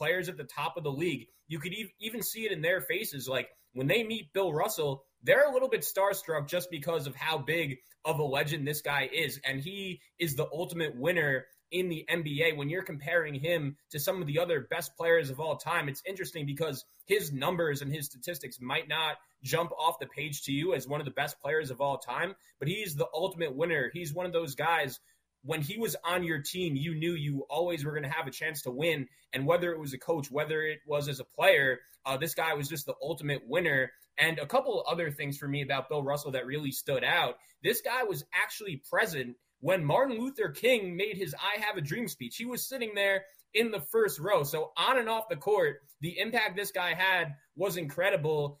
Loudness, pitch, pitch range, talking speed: -31 LUFS, 160 Hz, 145-180 Hz, 230 wpm